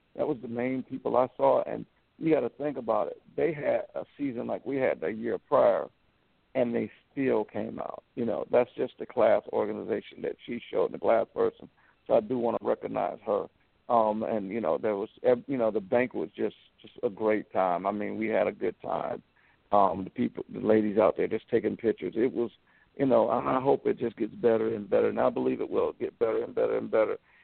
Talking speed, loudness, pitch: 230 wpm, -29 LUFS, 125 Hz